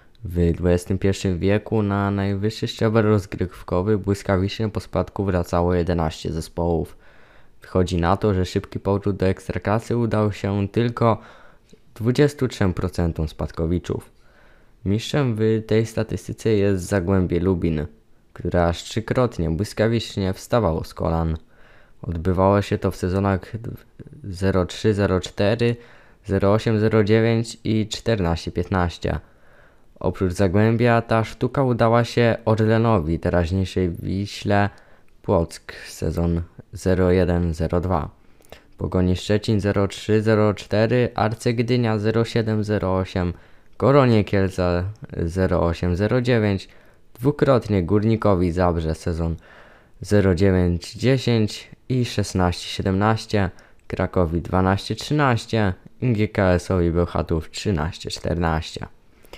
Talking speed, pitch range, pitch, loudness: 80 wpm, 90-110 Hz, 100 Hz, -22 LUFS